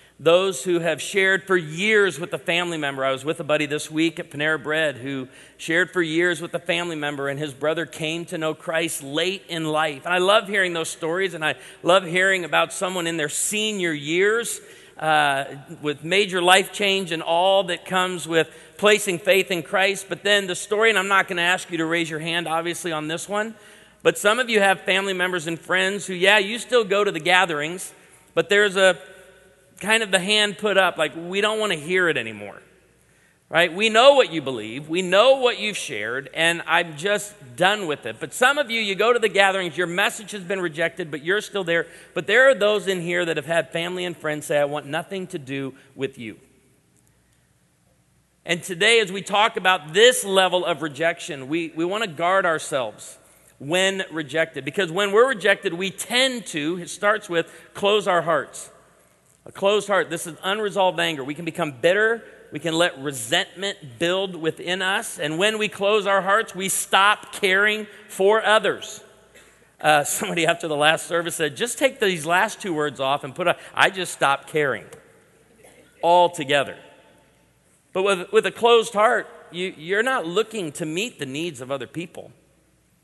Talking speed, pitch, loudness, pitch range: 200 wpm, 180 Hz, -21 LUFS, 160-200 Hz